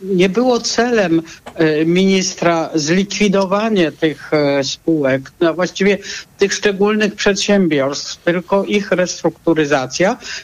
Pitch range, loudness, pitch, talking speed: 160-200 Hz, -15 LUFS, 180 Hz, 85 wpm